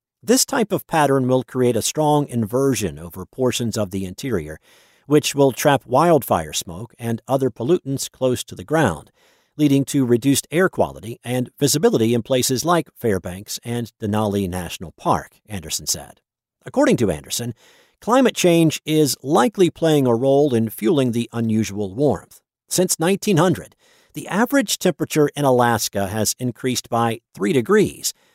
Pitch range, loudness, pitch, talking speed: 110-150 Hz, -19 LUFS, 130 Hz, 150 wpm